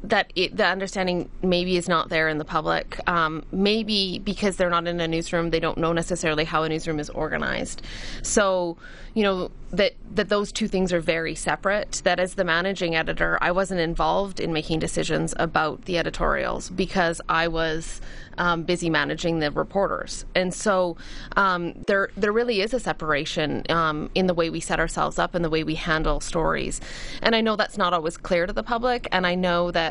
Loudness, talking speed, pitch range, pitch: -24 LUFS, 195 wpm, 160-195 Hz, 175 Hz